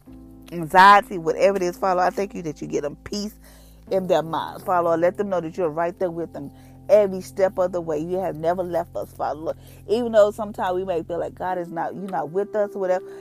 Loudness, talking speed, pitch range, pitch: -22 LUFS, 240 wpm, 170-200 Hz, 185 Hz